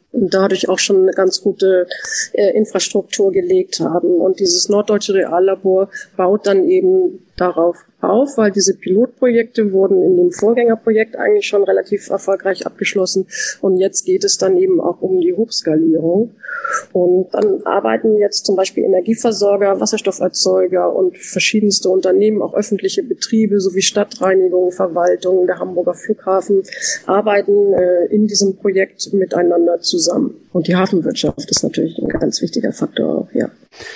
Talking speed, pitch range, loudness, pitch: 145 wpm, 185-225 Hz, -15 LUFS, 195 Hz